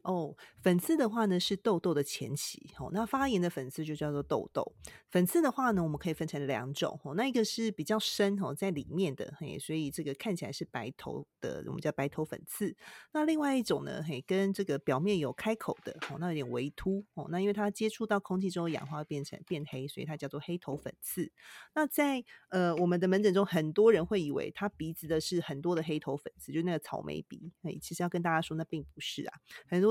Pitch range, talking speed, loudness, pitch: 150-200 Hz, 335 characters per minute, -33 LUFS, 175 Hz